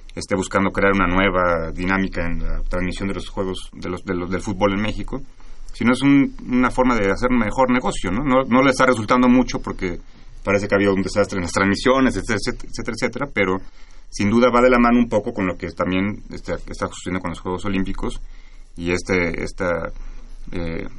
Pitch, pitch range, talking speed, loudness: 100 Hz, 90-125 Hz, 210 wpm, -20 LUFS